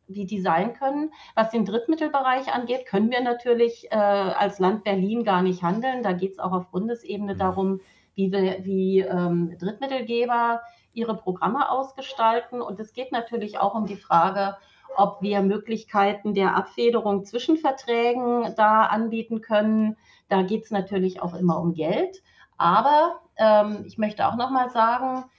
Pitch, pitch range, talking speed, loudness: 215 Hz, 195-240 Hz, 155 wpm, -24 LUFS